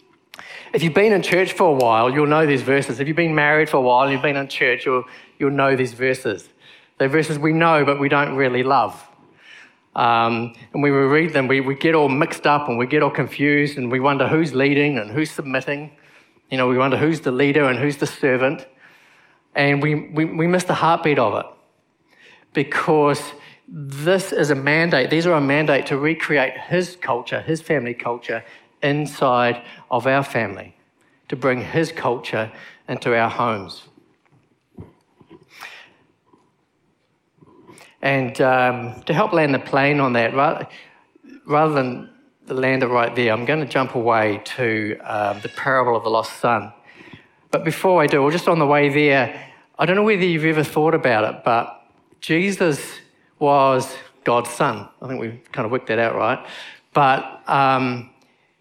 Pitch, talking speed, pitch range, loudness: 140 Hz, 180 wpm, 130-155 Hz, -19 LUFS